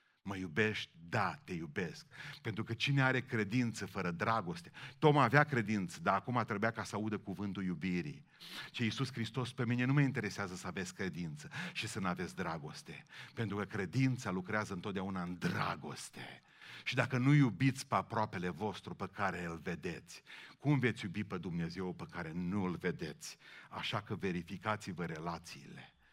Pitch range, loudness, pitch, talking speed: 95-125 Hz, -37 LUFS, 110 Hz, 165 wpm